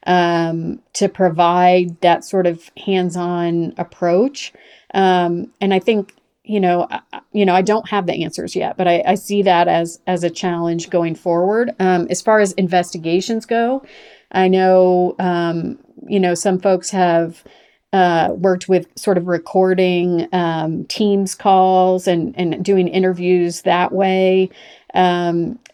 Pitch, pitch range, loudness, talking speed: 185 Hz, 175-195 Hz, -17 LUFS, 150 wpm